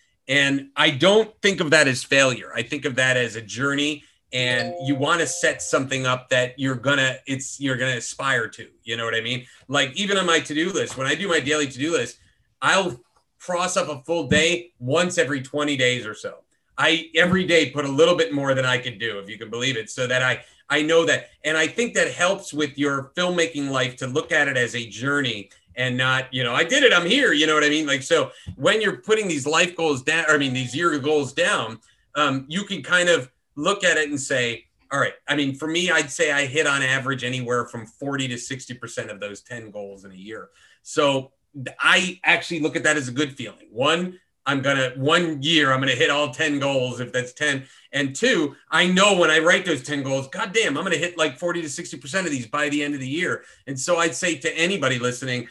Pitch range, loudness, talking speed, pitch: 130-165 Hz, -21 LUFS, 240 wpm, 145 Hz